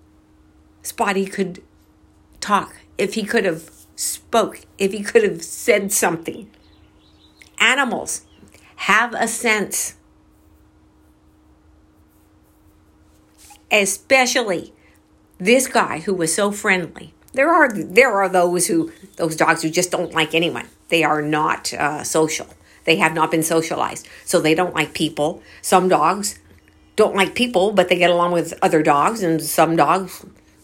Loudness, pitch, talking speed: -18 LUFS, 160 Hz, 135 wpm